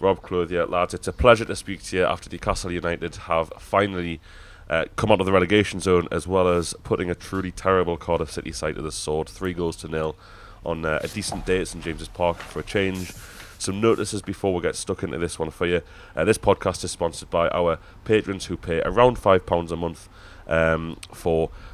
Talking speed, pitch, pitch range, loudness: 220 wpm, 90 Hz, 85-95 Hz, -24 LUFS